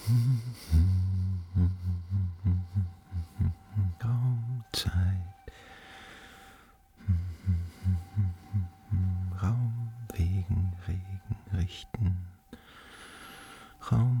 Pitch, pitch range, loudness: 95 Hz, 90-110 Hz, -31 LUFS